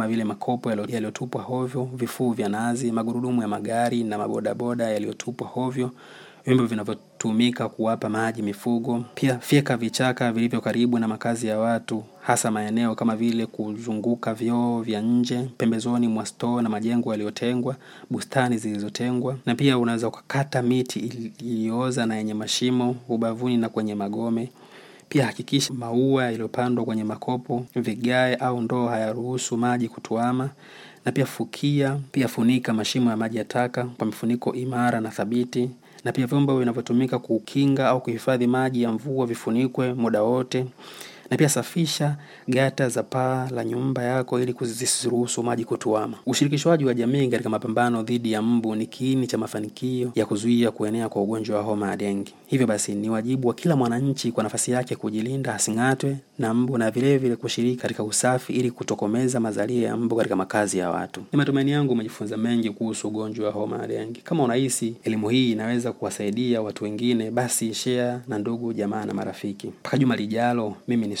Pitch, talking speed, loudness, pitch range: 120 Hz, 155 wpm, -24 LUFS, 110-125 Hz